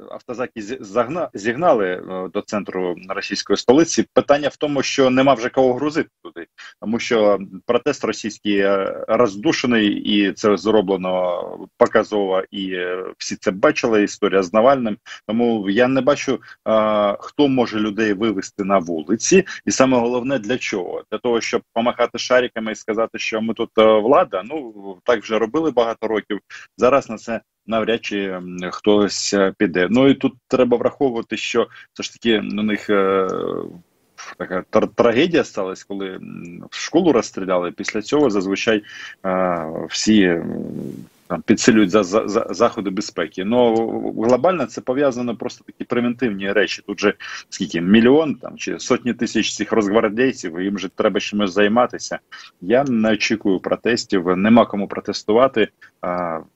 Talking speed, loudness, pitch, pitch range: 140 wpm, -19 LUFS, 110 Hz, 100-120 Hz